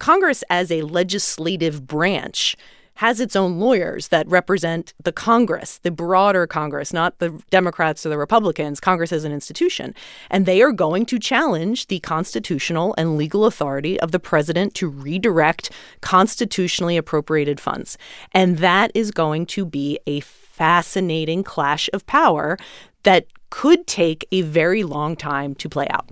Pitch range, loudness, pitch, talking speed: 160-195 Hz, -19 LUFS, 175 Hz, 150 wpm